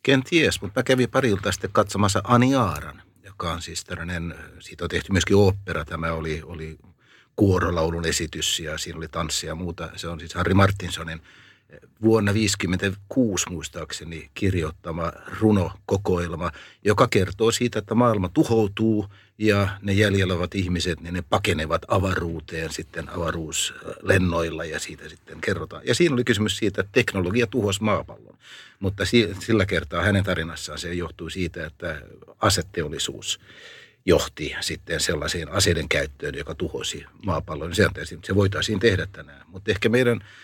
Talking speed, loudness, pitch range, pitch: 140 wpm, -24 LUFS, 85-105 Hz, 95 Hz